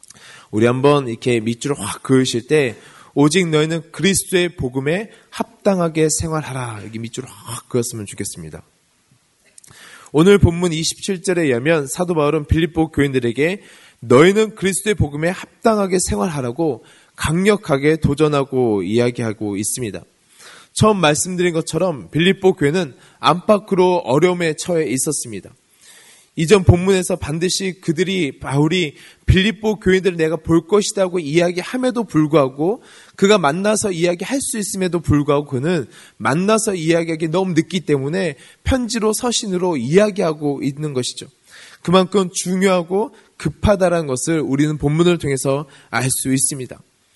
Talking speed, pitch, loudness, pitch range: 330 characters per minute, 165 Hz, -18 LUFS, 140-185 Hz